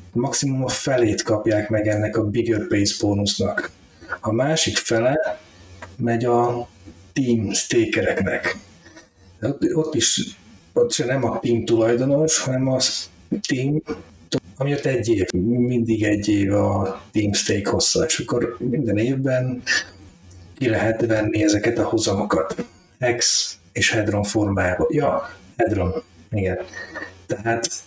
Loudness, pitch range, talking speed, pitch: -21 LUFS, 100-125 Hz, 125 wpm, 110 Hz